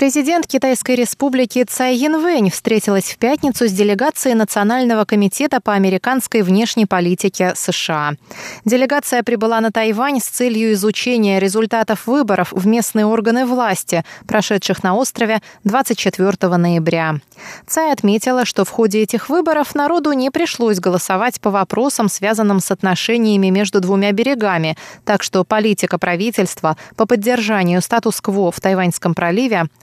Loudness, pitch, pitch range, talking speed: -16 LUFS, 220 Hz, 190-250 Hz, 130 wpm